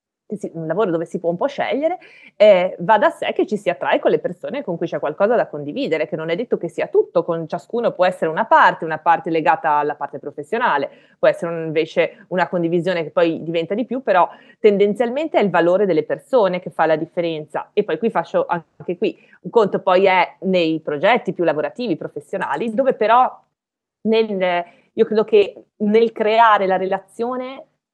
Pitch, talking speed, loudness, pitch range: 185 Hz, 195 wpm, -19 LUFS, 165-230 Hz